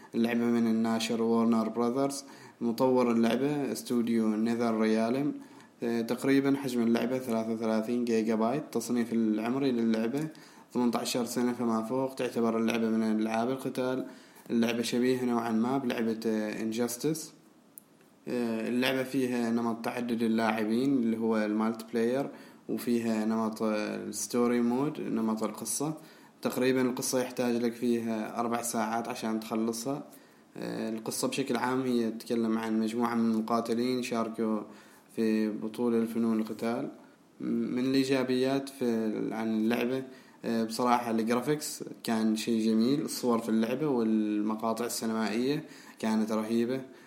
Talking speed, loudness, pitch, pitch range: 115 wpm, -30 LUFS, 115 Hz, 110-125 Hz